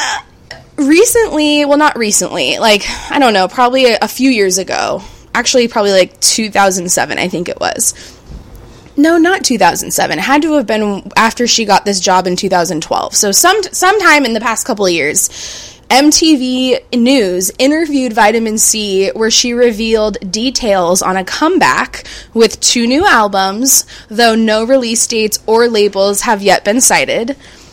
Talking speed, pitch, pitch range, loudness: 155 wpm, 230 Hz, 205-270 Hz, -11 LUFS